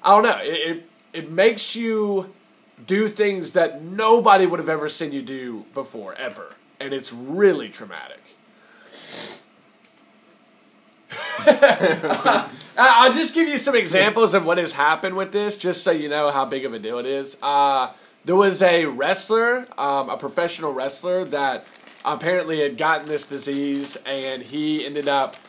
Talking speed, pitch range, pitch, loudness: 160 wpm, 140-200 Hz, 165 Hz, -20 LUFS